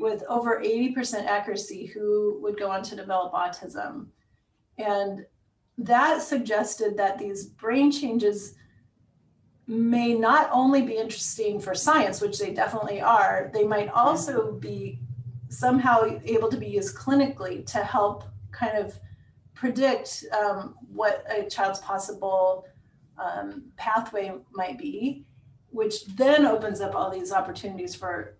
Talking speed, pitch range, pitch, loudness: 130 wpm, 195-240 Hz, 210 Hz, -26 LUFS